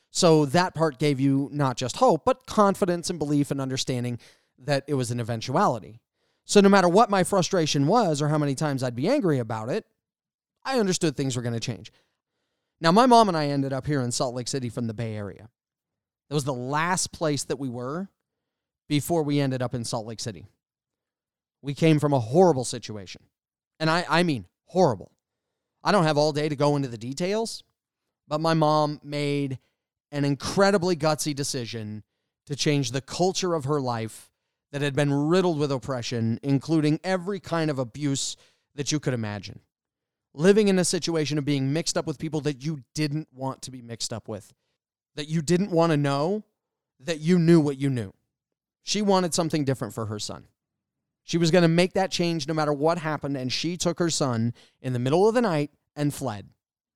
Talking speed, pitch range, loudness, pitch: 195 wpm, 130-165 Hz, -25 LUFS, 150 Hz